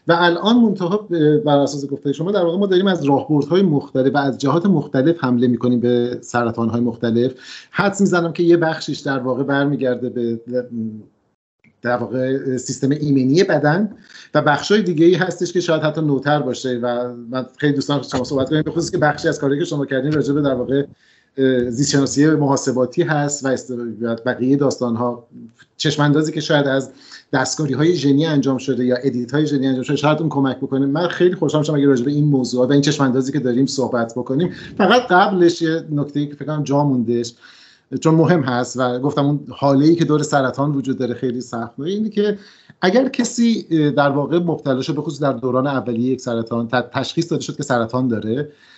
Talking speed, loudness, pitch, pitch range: 190 wpm, -18 LUFS, 140 Hz, 125-155 Hz